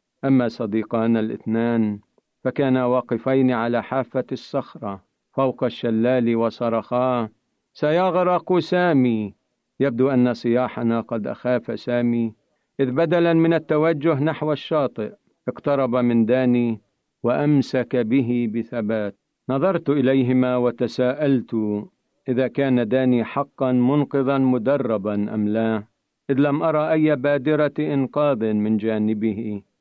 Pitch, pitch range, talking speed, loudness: 125 Hz, 115-140 Hz, 100 wpm, -21 LUFS